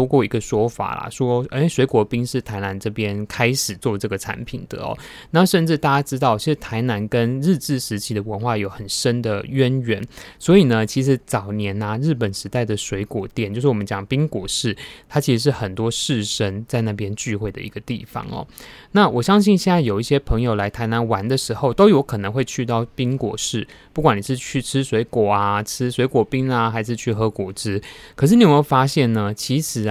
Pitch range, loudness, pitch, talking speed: 105-135 Hz, -20 LUFS, 120 Hz, 315 characters per minute